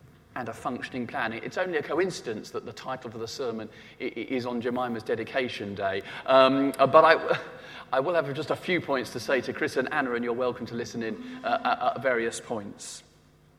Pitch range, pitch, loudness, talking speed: 120-140 Hz, 125 Hz, -27 LUFS, 195 wpm